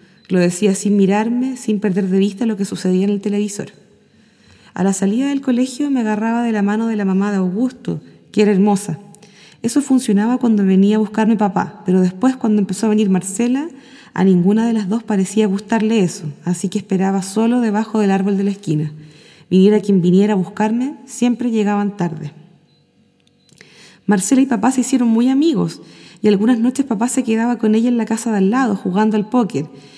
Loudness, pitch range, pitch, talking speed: -16 LUFS, 195-235 Hz, 210 Hz, 190 wpm